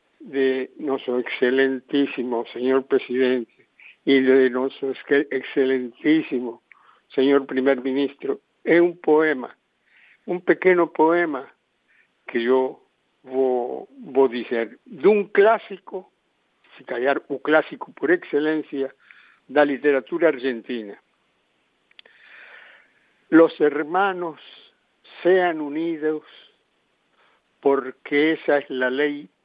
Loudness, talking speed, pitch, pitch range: -22 LUFS, 90 wpm, 140 Hz, 130-165 Hz